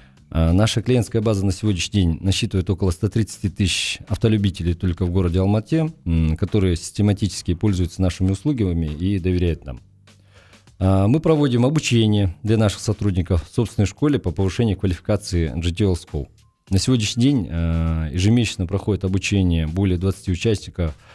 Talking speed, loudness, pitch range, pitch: 130 wpm, -20 LUFS, 90-110 Hz, 100 Hz